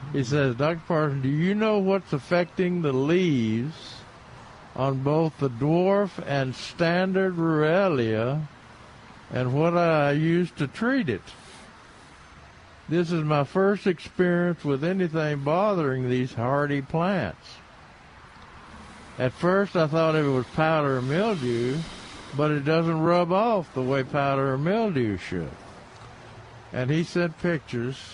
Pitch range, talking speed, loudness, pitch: 130-175 Hz, 130 wpm, -25 LUFS, 150 Hz